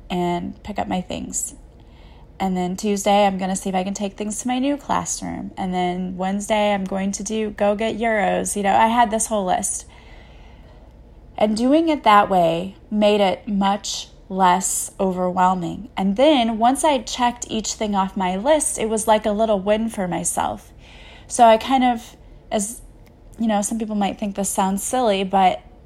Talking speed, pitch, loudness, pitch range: 190 wpm, 205 Hz, -20 LUFS, 190-225 Hz